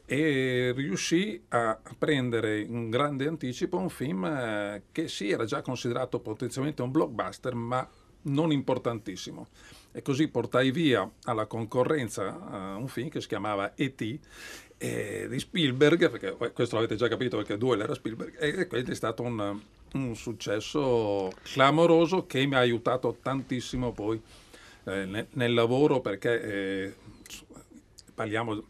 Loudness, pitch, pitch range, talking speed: -29 LUFS, 125 Hz, 110-145 Hz, 145 wpm